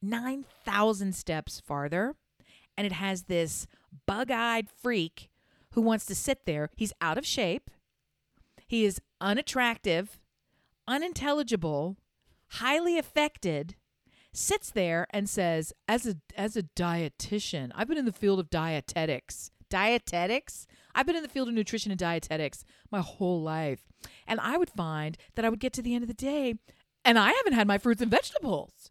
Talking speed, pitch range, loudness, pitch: 155 wpm, 170-240 Hz, -30 LUFS, 205 Hz